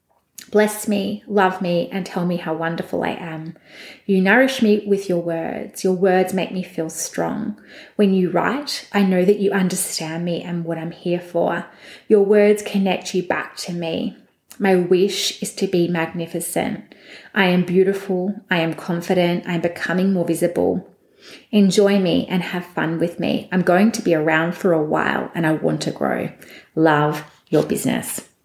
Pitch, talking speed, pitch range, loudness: 185 Hz, 175 wpm, 170-200 Hz, -20 LUFS